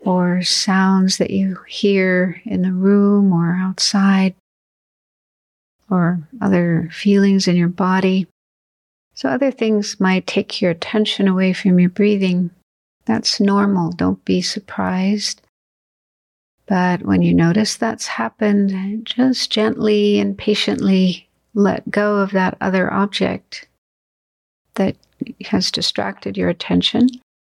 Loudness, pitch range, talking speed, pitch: -17 LUFS, 180-205 Hz, 115 wpm, 190 Hz